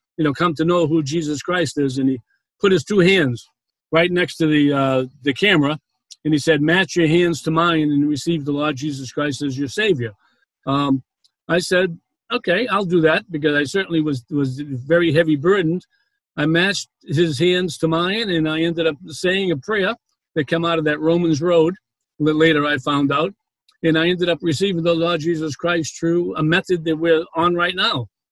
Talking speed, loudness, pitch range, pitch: 205 wpm, -19 LUFS, 145-175 Hz, 160 Hz